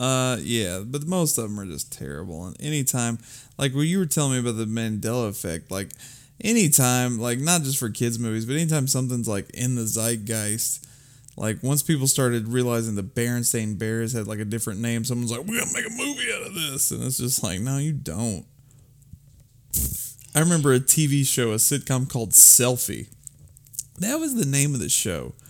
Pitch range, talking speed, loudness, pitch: 115-140 Hz, 195 wpm, -22 LUFS, 125 Hz